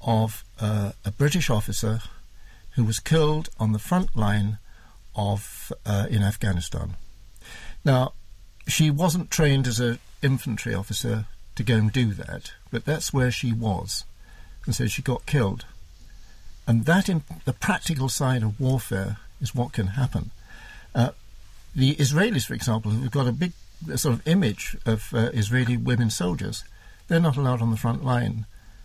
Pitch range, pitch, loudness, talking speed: 100-130 Hz, 115 Hz, -25 LUFS, 160 wpm